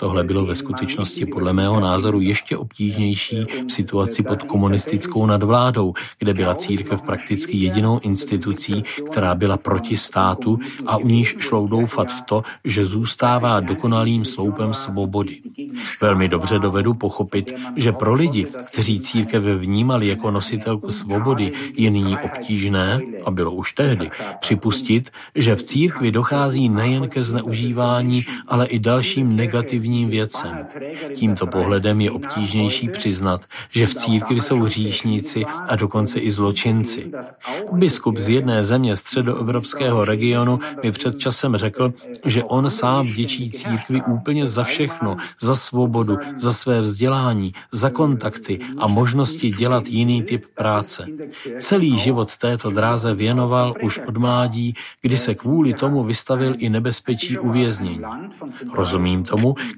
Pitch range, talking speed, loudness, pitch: 105-125 Hz, 130 wpm, -19 LUFS, 115 Hz